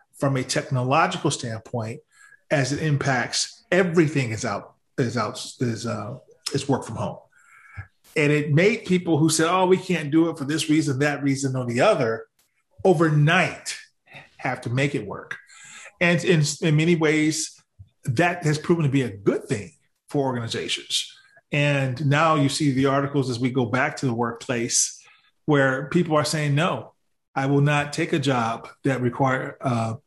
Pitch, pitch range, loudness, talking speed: 145 Hz, 130-165 Hz, -23 LUFS, 170 wpm